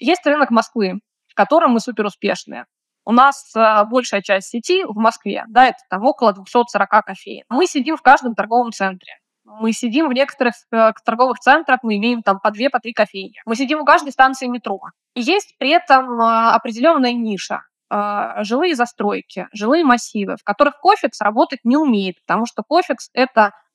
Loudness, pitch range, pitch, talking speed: -16 LUFS, 215-275 Hz, 240 Hz, 175 wpm